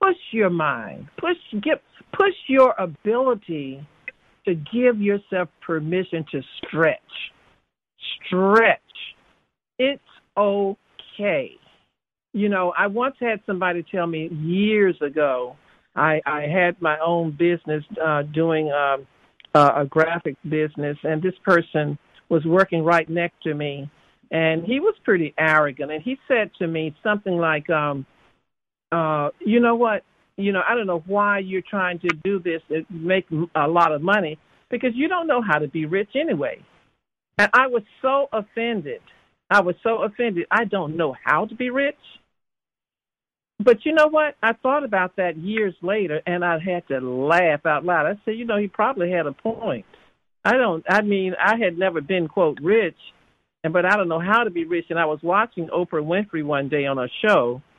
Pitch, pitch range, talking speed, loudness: 180 Hz, 160-215 Hz, 170 wpm, -21 LUFS